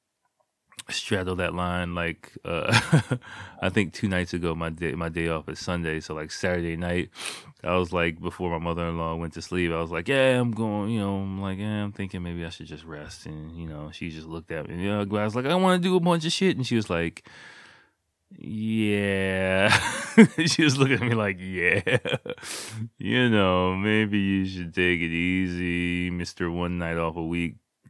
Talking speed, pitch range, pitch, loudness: 205 wpm, 85-105 Hz, 90 Hz, -25 LUFS